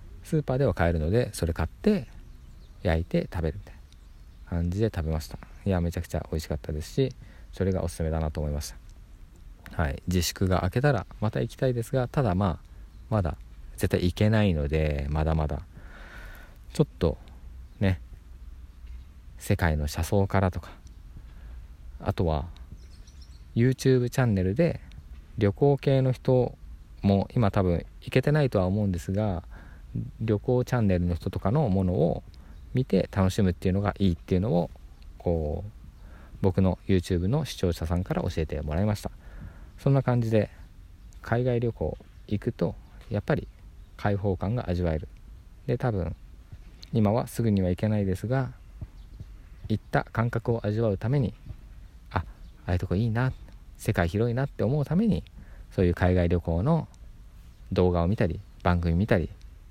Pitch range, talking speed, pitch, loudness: 80-105 Hz, 315 characters per minute, 90 Hz, -27 LUFS